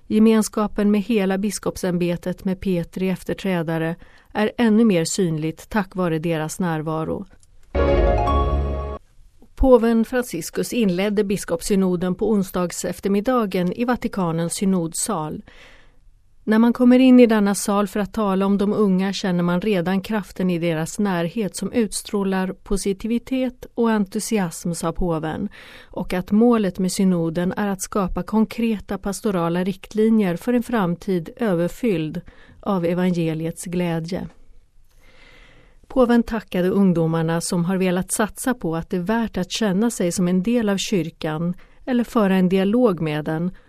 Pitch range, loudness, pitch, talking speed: 175-215 Hz, -21 LUFS, 190 Hz, 130 wpm